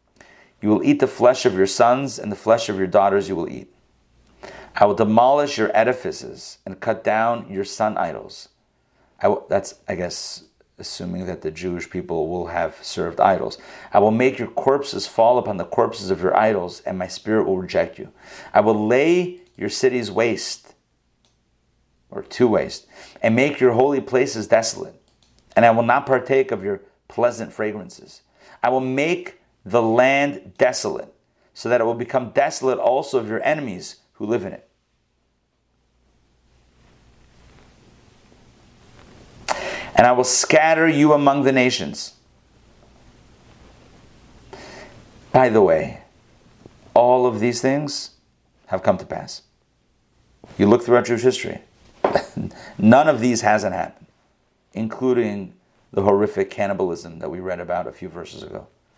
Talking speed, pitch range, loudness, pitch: 150 wpm, 105-135 Hz, -20 LUFS, 120 Hz